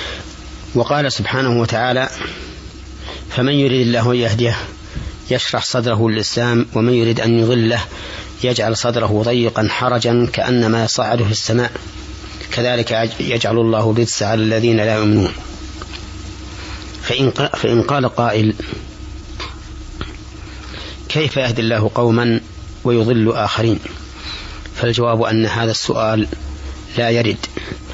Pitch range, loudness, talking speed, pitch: 95-120 Hz, -16 LUFS, 100 wpm, 115 Hz